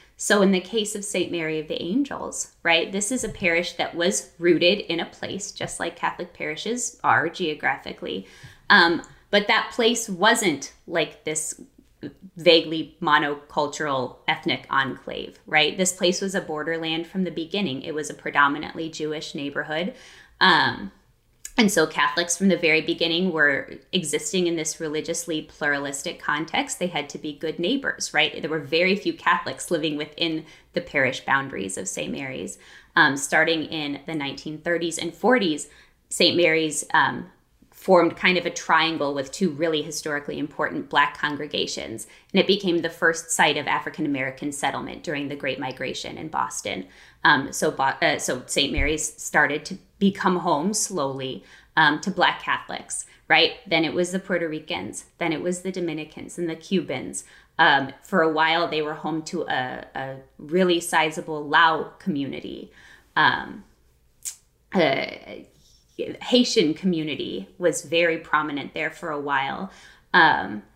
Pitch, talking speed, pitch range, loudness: 165 Hz, 155 wpm, 150-180 Hz, -23 LUFS